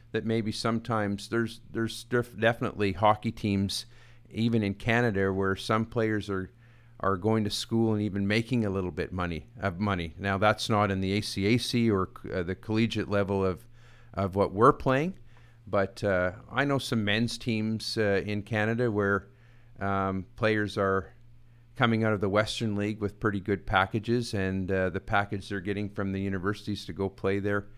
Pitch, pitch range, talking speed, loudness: 105 Hz, 100-115 Hz, 175 wpm, -29 LUFS